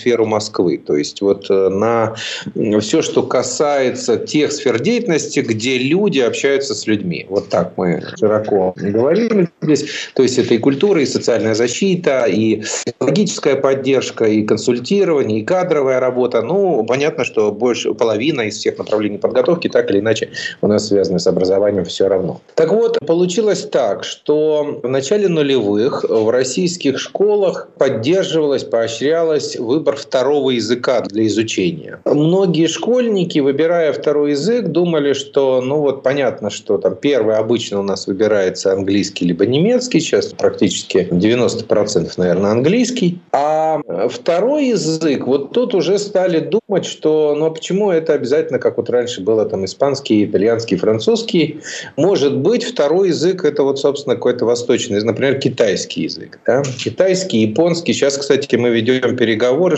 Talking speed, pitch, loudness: 145 wpm, 160 Hz, -16 LUFS